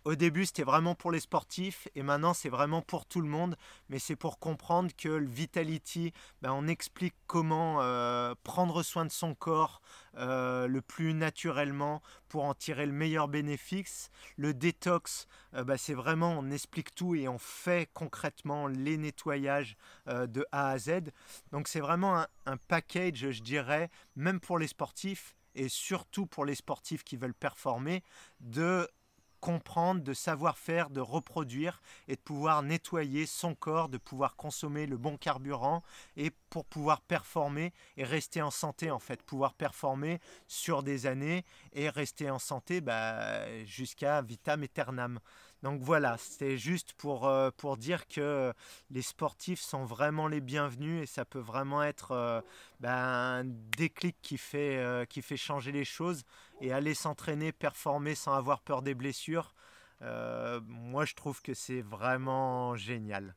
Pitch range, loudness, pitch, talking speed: 135-165 Hz, -35 LUFS, 145 Hz, 165 wpm